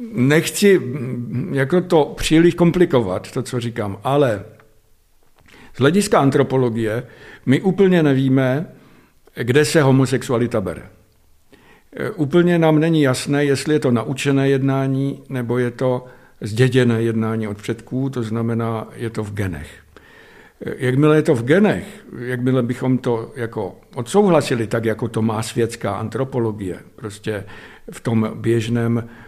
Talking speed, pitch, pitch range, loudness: 125 wpm, 125 Hz, 110-140 Hz, -18 LUFS